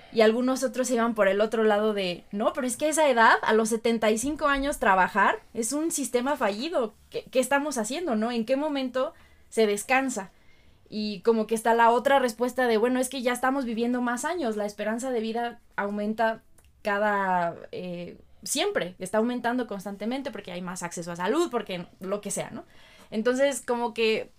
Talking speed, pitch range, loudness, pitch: 185 wpm, 210-260 Hz, -26 LUFS, 230 Hz